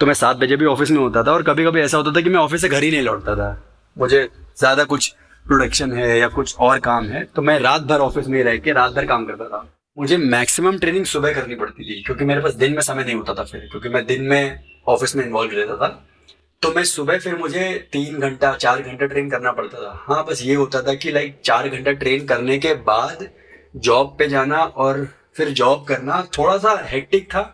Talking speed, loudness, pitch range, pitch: 240 wpm, -18 LUFS, 125-155 Hz, 140 Hz